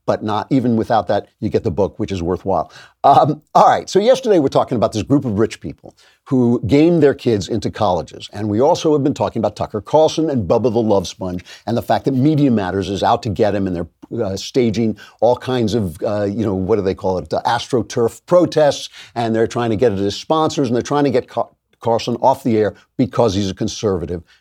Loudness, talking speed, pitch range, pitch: -17 LUFS, 235 wpm, 100-130 Hz, 115 Hz